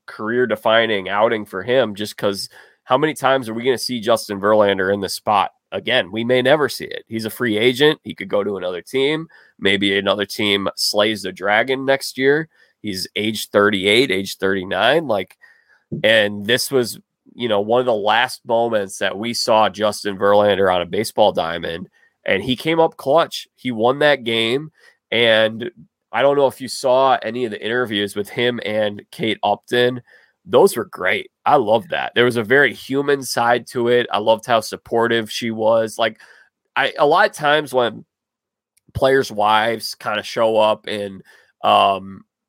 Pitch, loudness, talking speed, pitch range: 115 Hz, -18 LUFS, 180 wpm, 105-130 Hz